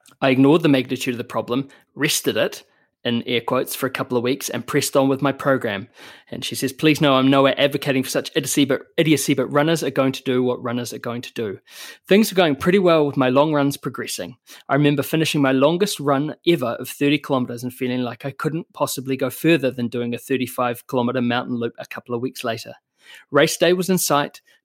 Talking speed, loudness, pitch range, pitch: 225 wpm, -20 LUFS, 125-145 Hz, 135 Hz